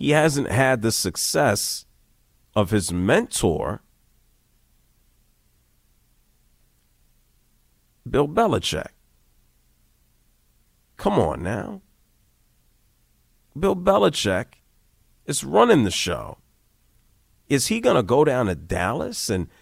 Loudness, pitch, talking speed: -22 LUFS, 105 Hz, 85 wpm